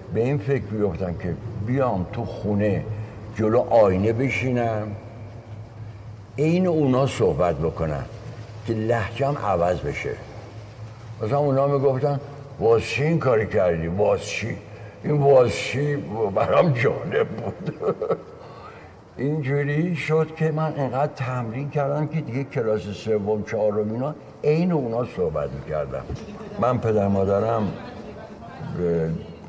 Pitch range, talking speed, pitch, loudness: 105-140 Hz, 110 wpm, 115 Hz, -23 LUFS